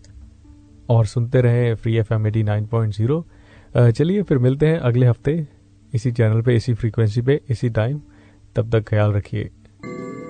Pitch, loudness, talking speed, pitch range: 115 Hz, -19 LUFS, 145 wpm, 105-125 Hz